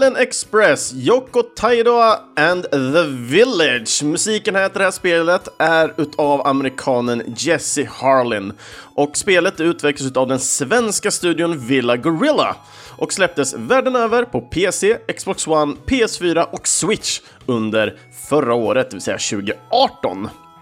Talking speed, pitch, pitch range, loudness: 130 wpm, 165 Hz, 130-205 Hz, -17 LUFS